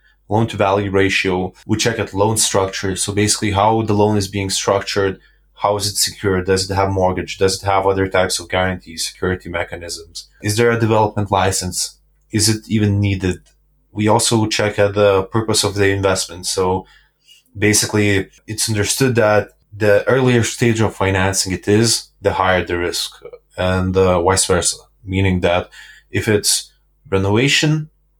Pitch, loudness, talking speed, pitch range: 100 Hz, -17 LUFS, 165 wpm, 95-110 Hz